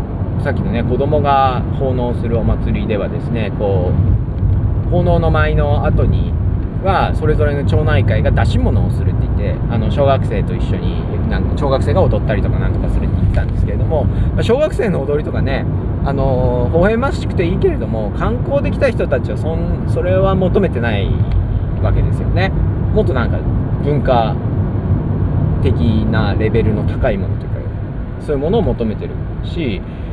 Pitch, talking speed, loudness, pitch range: 105 Hz, 345 characters per minute, -16 LUFS, 95-115 Hz